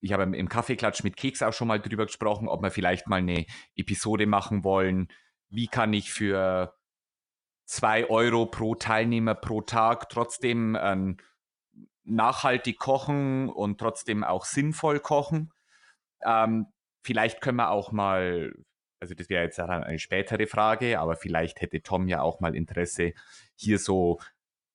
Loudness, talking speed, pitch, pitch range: -27 LUFS, 150 wpm, 105 Hz, 95-115 Hz